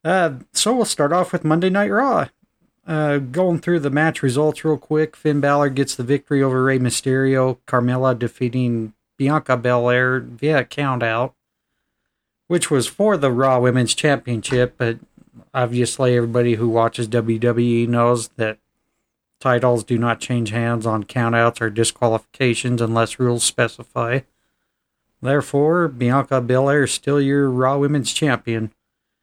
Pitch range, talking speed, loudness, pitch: 120-145 Hz, 140 wpm, -19 LUFS, 130 Hz